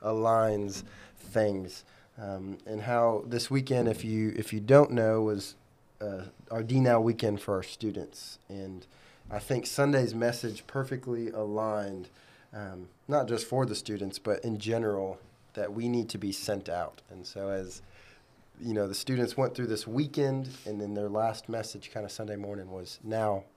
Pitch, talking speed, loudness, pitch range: 110 Hz, 170 wpm, -31 LUFS, 100-120 Hz